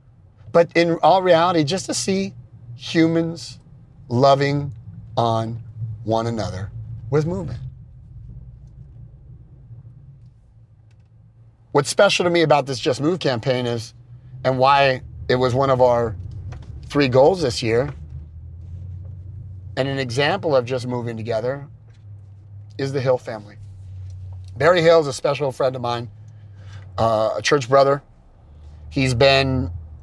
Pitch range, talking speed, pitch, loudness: 110-135 Hz, 120 wpm, 120 Hz, -19 LUFS